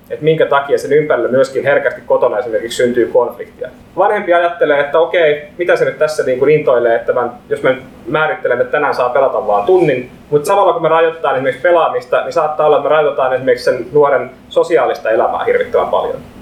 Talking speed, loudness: 195 wpm, -13 LUFS